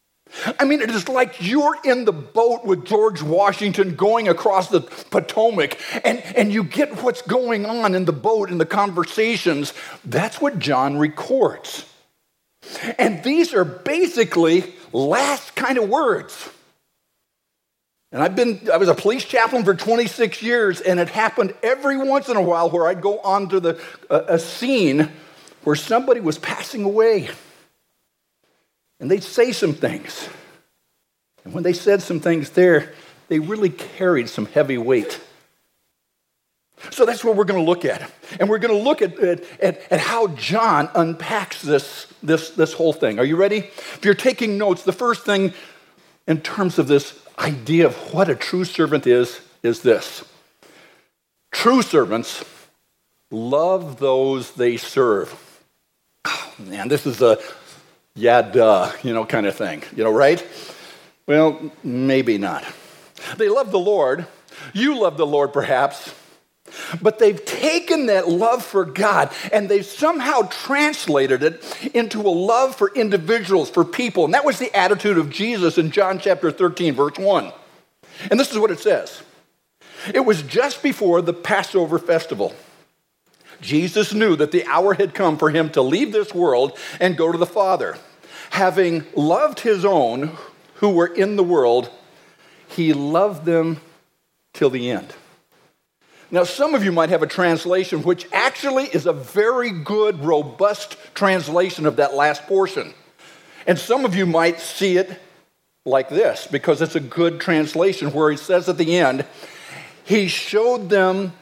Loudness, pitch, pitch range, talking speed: -19 LUFS, 190 Hz, 165-220 Hz, 155 wpm